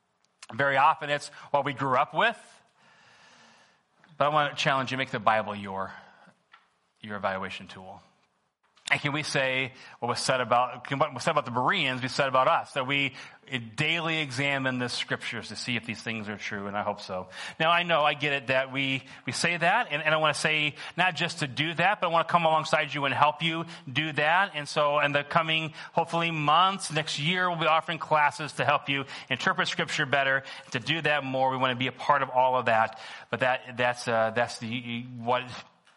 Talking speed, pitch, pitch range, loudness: 220 wpm, 140 Hz, 125-155 Hz, -27 LUFS